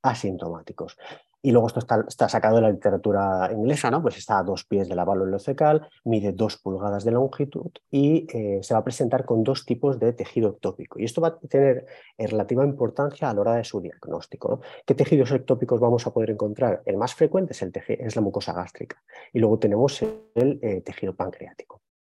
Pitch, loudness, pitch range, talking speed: 120 Hz, -24 LUFS, 105-140 Hz, 205 wpm